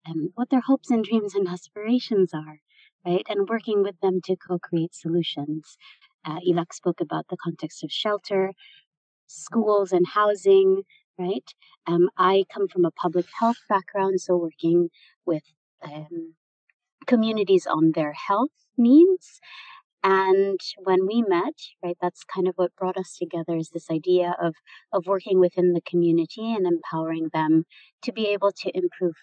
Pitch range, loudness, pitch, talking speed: 170-210 Hz, -24 LUFS, 185 Hz, 155 wpm